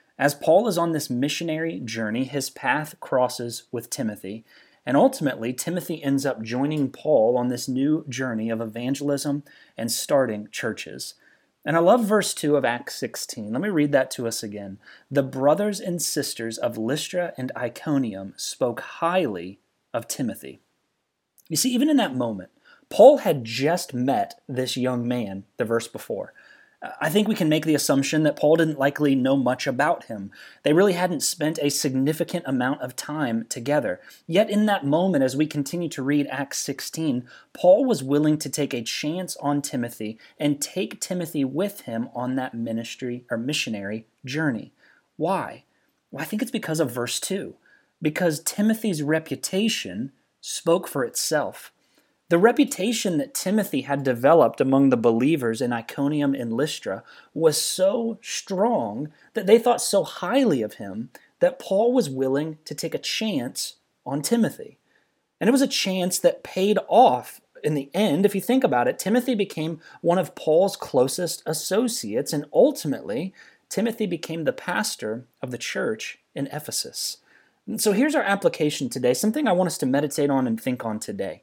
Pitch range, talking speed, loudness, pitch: 130-190 Hz, 165 wpm, -24 LUFS, 150 Hz